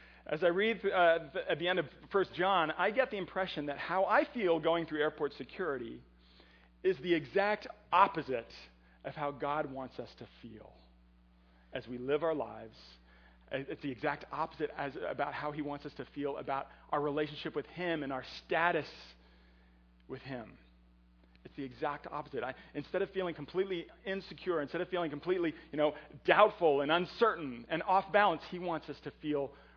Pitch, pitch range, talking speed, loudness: 150 Hz, 130-180 Hz, 175 wpm, -34 LUFS